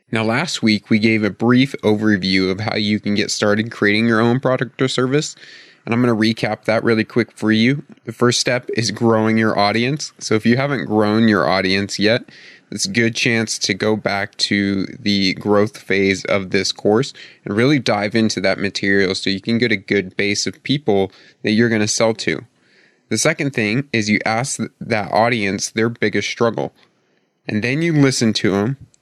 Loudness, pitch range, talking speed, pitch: -17 LUFS, 105-120 Hz, 200 wpm, 110 Hz